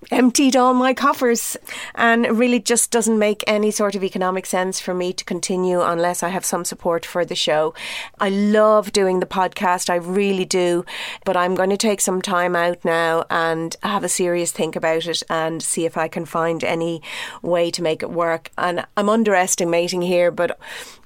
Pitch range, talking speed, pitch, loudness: 170-205 Hz, 195 wpm, 180 Hz, -19 LUFS